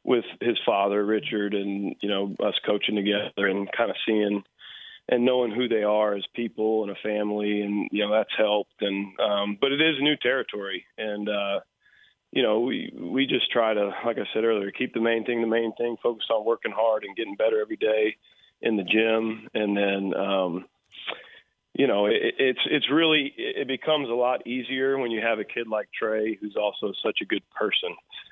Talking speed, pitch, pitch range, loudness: 200 wpm, 110 Hz, 105-125 Hz, -25 LUFS